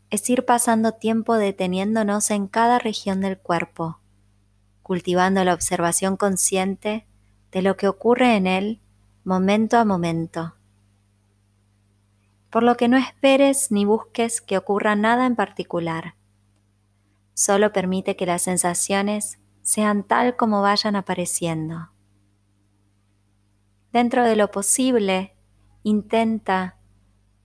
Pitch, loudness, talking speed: 185 Hz, -20 LUFS, 110 wpm